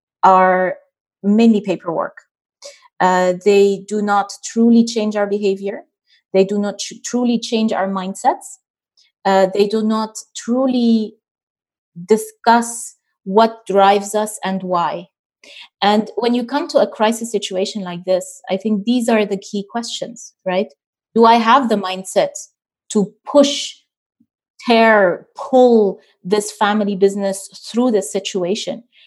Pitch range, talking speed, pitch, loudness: 195-235 Hz, 130 wpm, 210 Hz, -16 LUFS